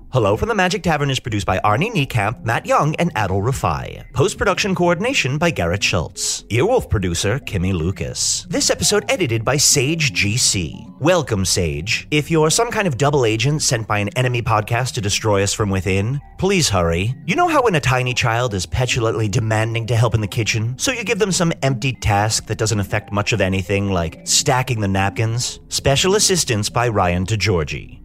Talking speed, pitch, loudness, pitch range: 195 wpm, 115 Hz, -18 LUFS, 100-145 Hz